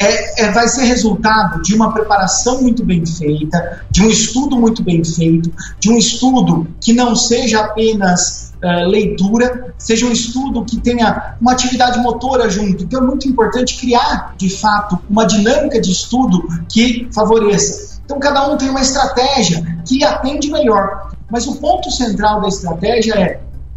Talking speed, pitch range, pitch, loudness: 160 wpm, 195-245 Hz, 220 Hz, -13 LUFS